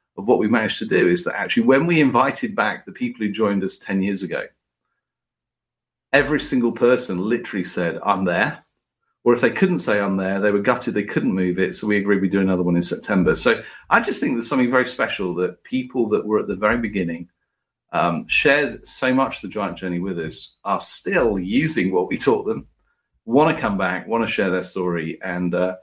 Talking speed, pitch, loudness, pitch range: 220 wpm, 100 Hz, -20 LUFS, 90-120 Hz